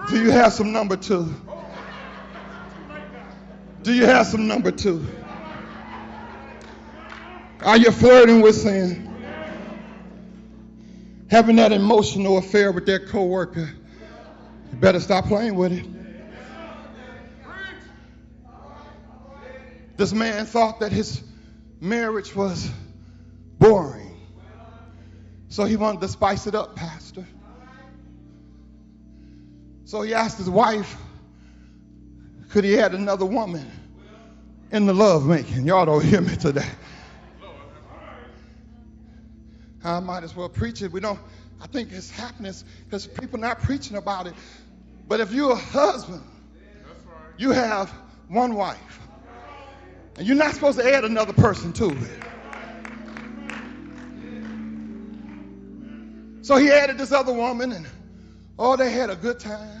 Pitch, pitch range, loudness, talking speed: 205 Hz, 165-225 Hz, -20 LUFS, 115 wpm